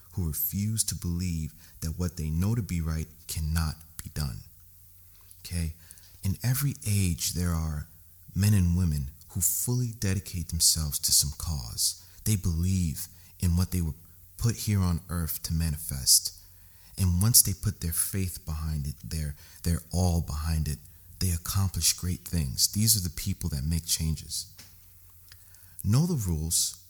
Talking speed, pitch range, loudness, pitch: 155 wpm, 80-95 Hz, -28 LUFS, 90 Hz